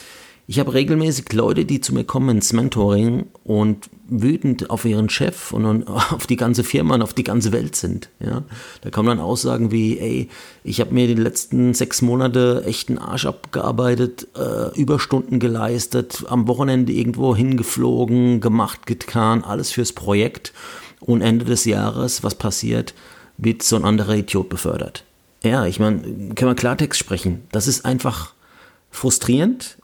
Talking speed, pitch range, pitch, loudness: 155 wpm, 110-125 Hz, 120 Hz, -19 LUFS